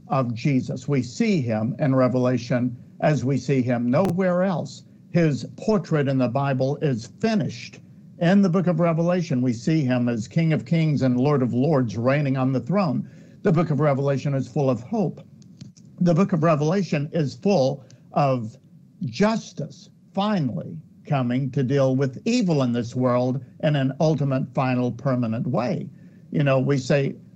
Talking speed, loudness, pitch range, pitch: 165 wpm, -23 LUFS, 130-175 Hz, 145 Hz